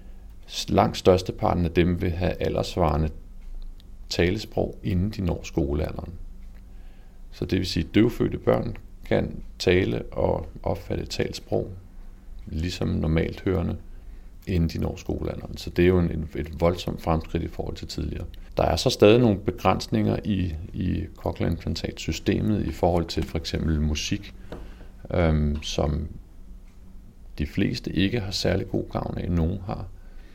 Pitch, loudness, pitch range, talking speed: 90 Hz, -26 LUFS, 85-95 Hz, 140 wpm